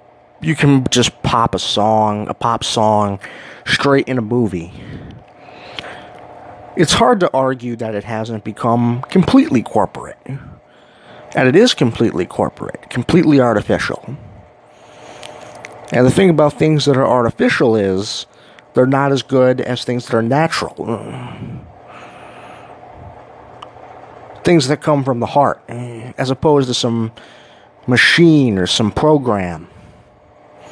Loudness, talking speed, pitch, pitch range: -15 LUFS, 120 wpm, 125 Hz, 110-145 Hz